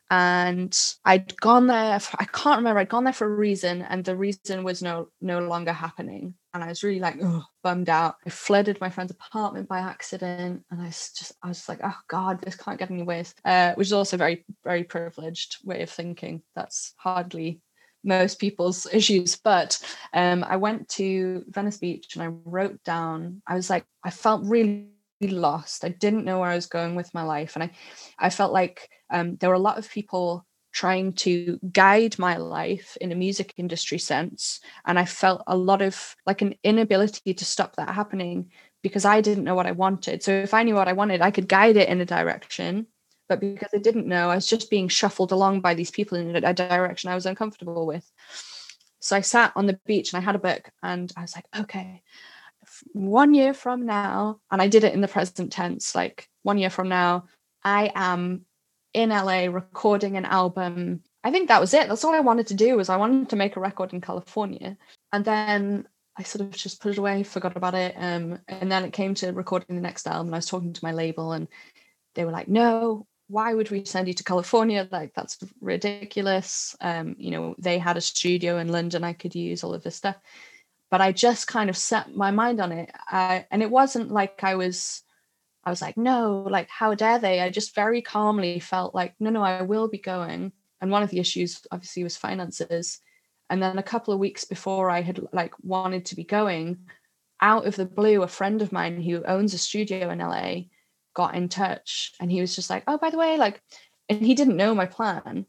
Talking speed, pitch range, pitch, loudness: 220 wpm, 180-205 Hz, 185 Hz, -24 LUFS